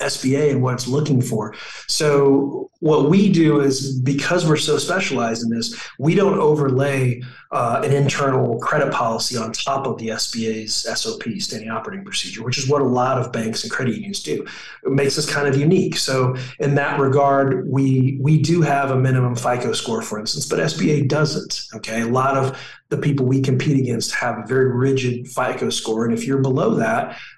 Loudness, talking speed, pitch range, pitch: -19 LUFS, 195 wpm, 125-145 Hz, 135 Hz